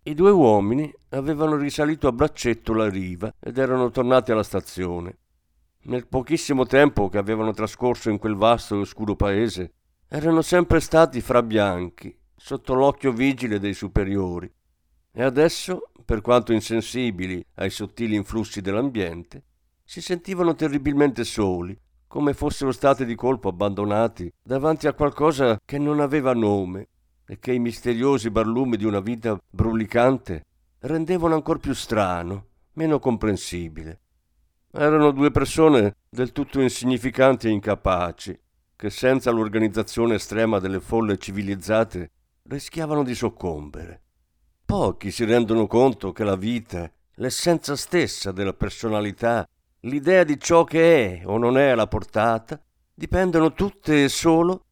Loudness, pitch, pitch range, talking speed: -22 LUFS, 115 Hz, 100-140 Hz, 130 wpm